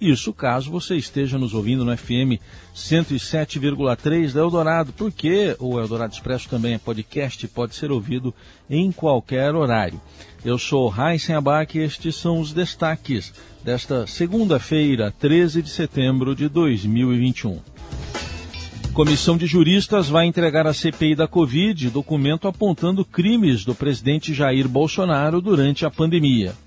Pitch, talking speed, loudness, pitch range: 145 Hz, 135 wpm, -20 LUFS, 120-165 Hz